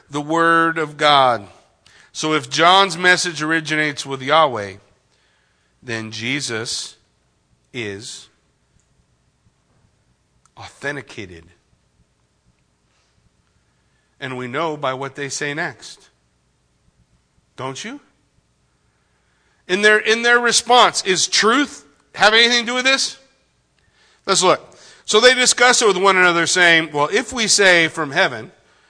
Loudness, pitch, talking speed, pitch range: -16 LUFS, 155 Hz, 110 wpm, 120-195 Hz